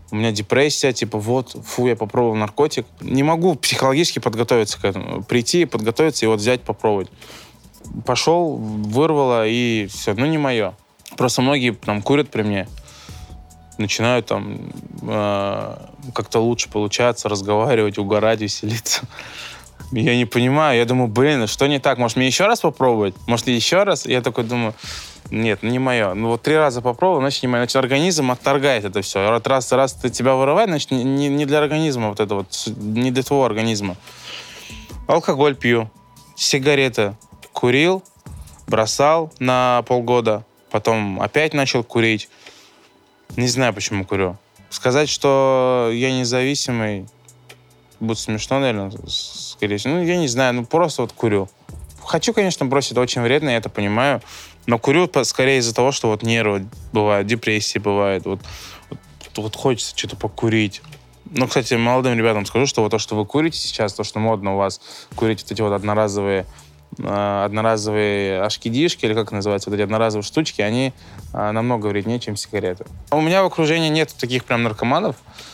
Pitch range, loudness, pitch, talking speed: 105-135 Hz, -19 LUFS, 120 Hz, 160 wpm